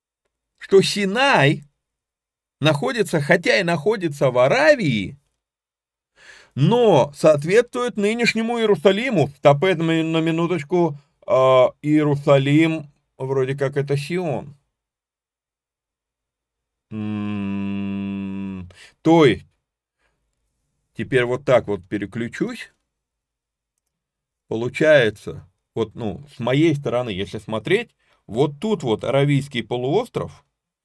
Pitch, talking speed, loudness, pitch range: 140 Hz, 80 wpm, -19 LUFS, 105-165 Hz